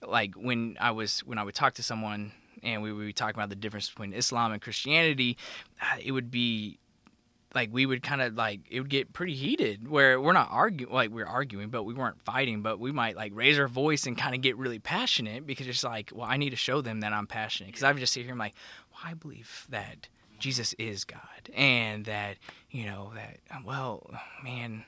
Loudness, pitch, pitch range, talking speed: -29 LUFS, 120 Hz, 110-130 Hz, 230 wpm